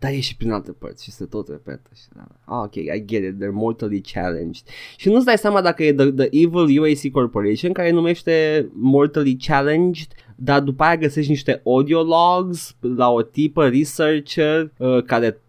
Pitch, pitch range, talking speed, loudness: 140 Hz, 115-155 Hz, 180 wpm, -18 LUFS